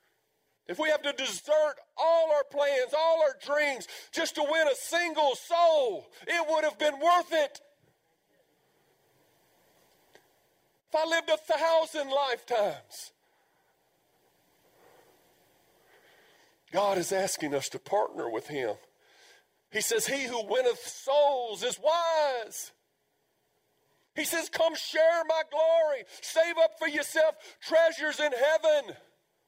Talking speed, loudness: 120 wpm, -28 LUFS